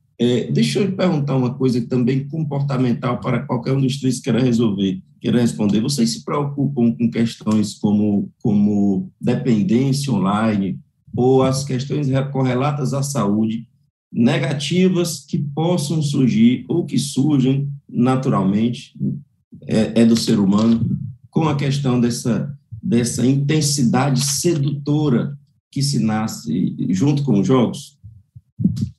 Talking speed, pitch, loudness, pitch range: 125 wpm, 130 Hz, -19 LUFS, 115-145 Hz